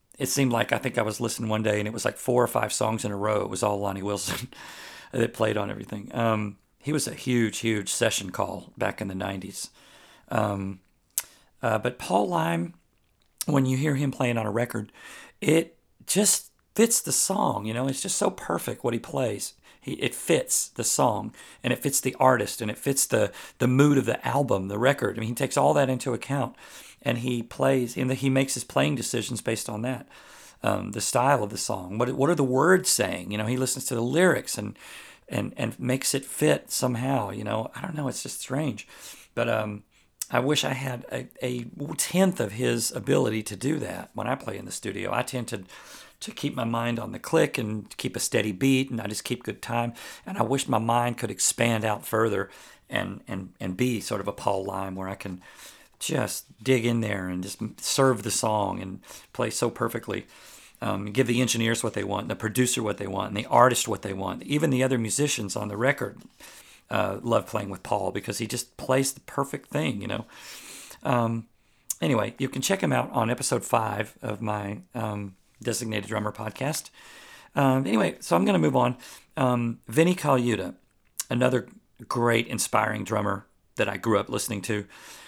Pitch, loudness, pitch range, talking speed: 120 Hz, -26 LUFS, 105-135 Hz, 210 wpm